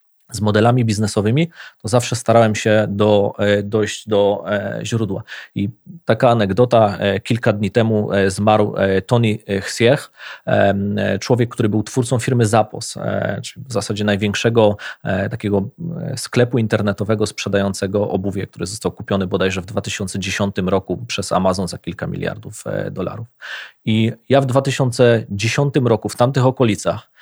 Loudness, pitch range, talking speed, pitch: -18 LUFS, 100-120 Hz, 125 wpm, 110 Hz